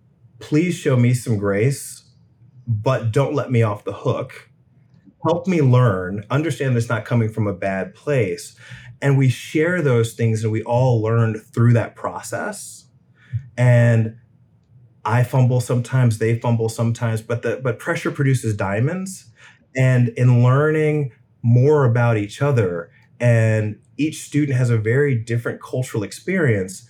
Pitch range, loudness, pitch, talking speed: 115-135 Hz, -19 LUFS, 120 Hz, 145 wpm